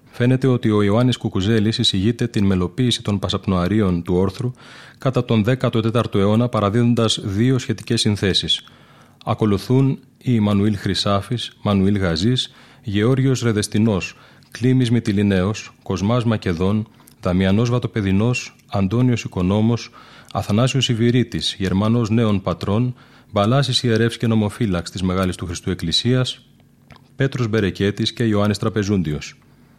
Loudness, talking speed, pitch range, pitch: -19 LUFS, 110 wpm, 100-125 Hz, 110 Hz